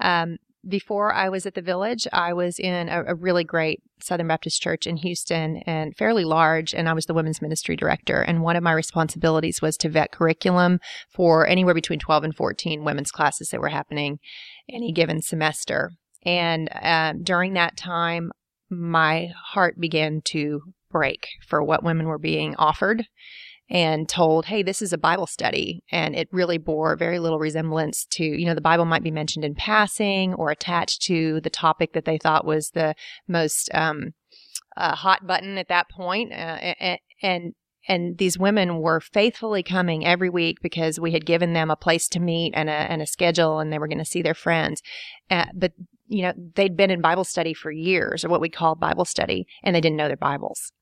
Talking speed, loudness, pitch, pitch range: 195 wpm, -23 LUFS, 170 Hz, 160-180 Hz